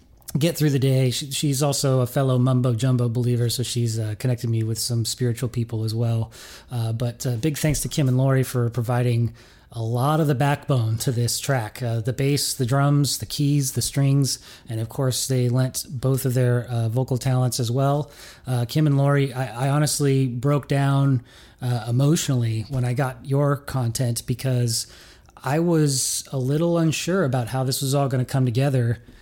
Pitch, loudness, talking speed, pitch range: 130 Hz, -22 LUFS, 195 wpm, 120-140 Hz